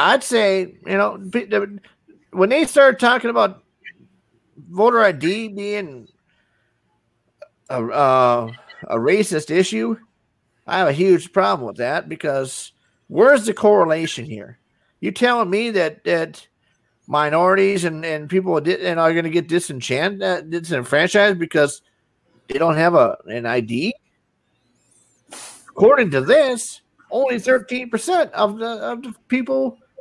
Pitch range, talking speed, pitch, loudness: 160-230 Hz, 130 wpm, 190 Hz, -18 LUFS